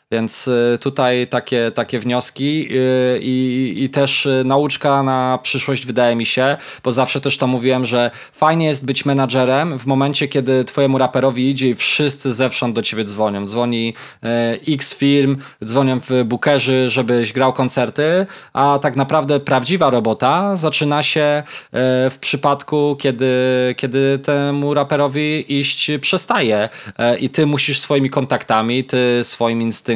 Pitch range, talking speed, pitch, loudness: 125-140 Hz, 135 wpm, 130 Hz, -16 LUFS